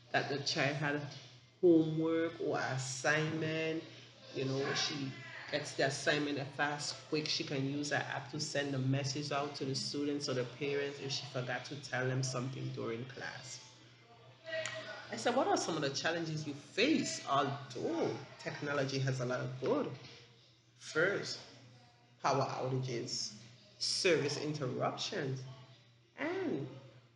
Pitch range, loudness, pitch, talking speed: 125-145 Hz, -36 LUFS, 135 Hz, 140 wpm